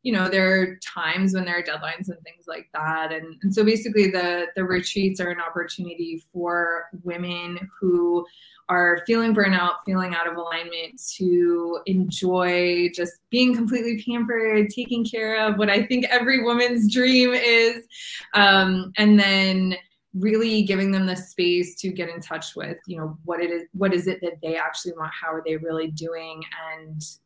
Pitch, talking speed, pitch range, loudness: 180 Hz, 175 wpm, 170-210 Hz, -22 LUFS